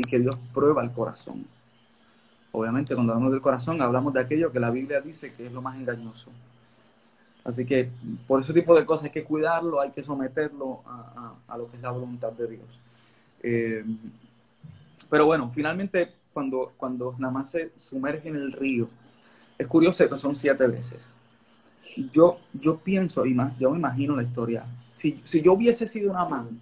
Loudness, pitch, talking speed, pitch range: -26 LUFS, 130 Hz, 185 wpm, 120-150 Hz